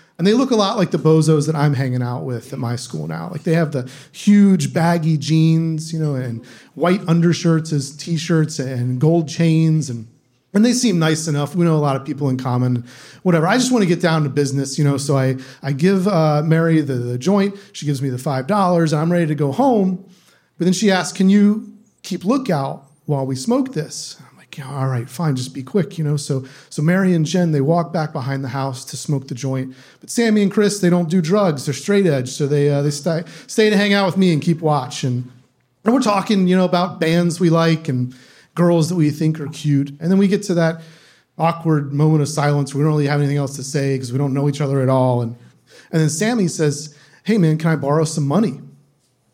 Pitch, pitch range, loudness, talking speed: 155 Hz, 140-180 Hz, -18 LUFS, 235 wpm